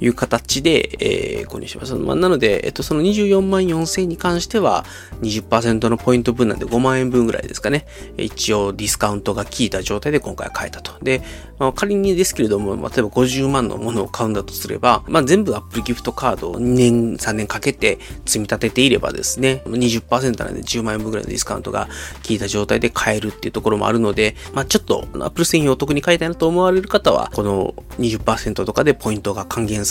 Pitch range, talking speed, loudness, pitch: 110-145 Hz, 420 characters per minute, -18 LUFS, 120 Hz